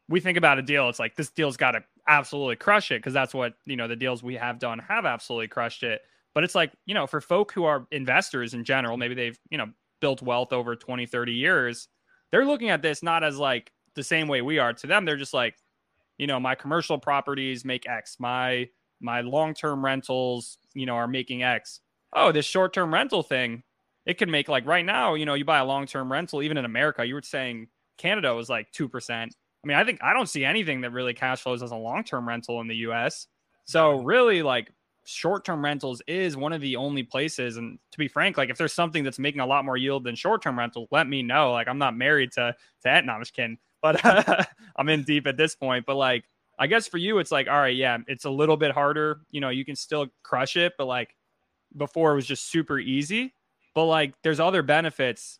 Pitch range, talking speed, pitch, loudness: 125-155 Hz, 235 wpm, 135 Hz, -25 LUFS